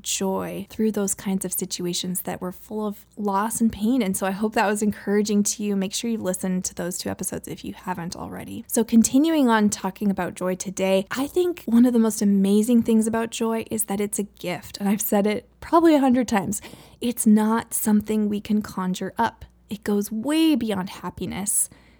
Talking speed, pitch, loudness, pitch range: 205 wpm, 210 Hz, -23 LUFS, 190-225 Hz